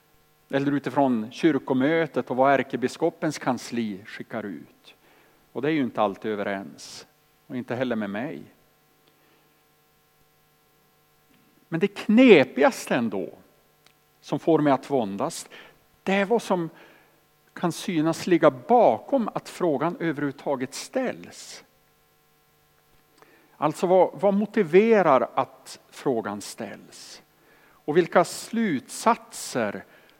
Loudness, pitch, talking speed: -24 LUFS, 135 Hz, 105 wpm